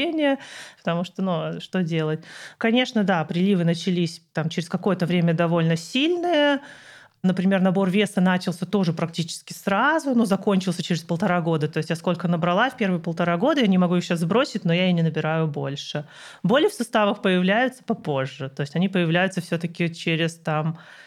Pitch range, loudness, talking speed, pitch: 165-205 Hz, -23 LUFS, 175 wpm, 180 Hz